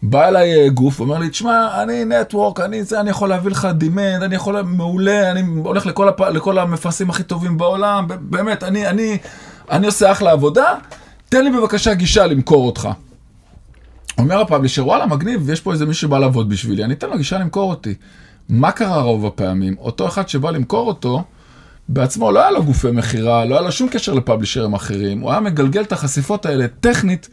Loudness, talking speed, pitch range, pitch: -16 LUFS, 190 wpm, 130-200 Hz, 175 Hz